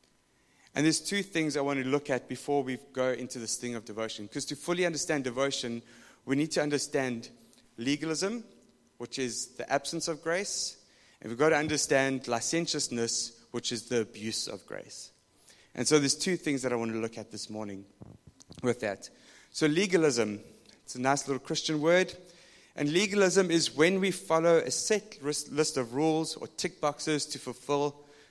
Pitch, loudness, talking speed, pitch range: 145 Hz, -30 LUFS, 180 wpm, 120-160 Hz